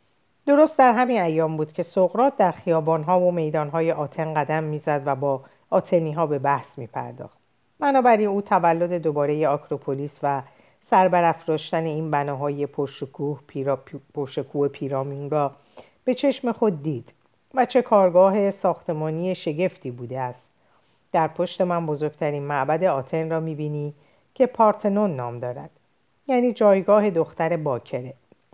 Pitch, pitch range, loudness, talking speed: 160 Hz, 145-185 Hz, -23 LUFS, 130 wpm